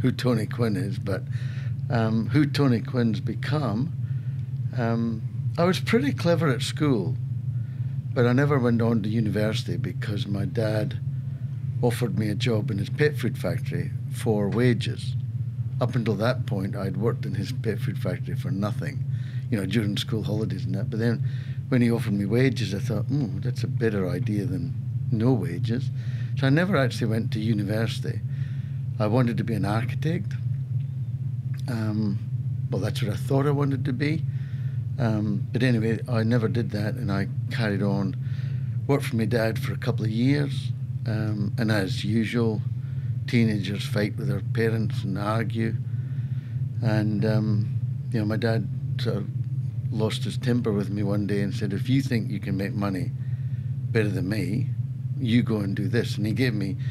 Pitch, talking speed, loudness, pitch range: 125 Hz, 175 wpm, -26 LUFS, 115-130 Hz